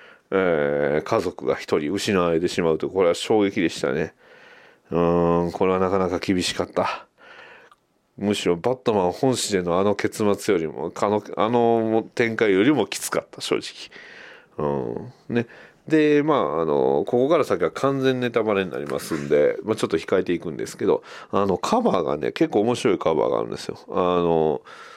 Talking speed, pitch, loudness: 335 characters per minute, 120 Hz, -22 LUFS